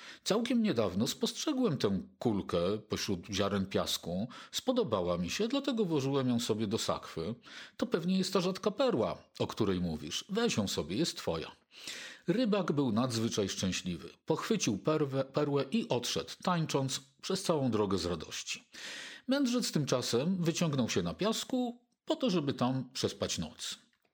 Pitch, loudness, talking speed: 160 Hz, -33 LUFS, 140 wpm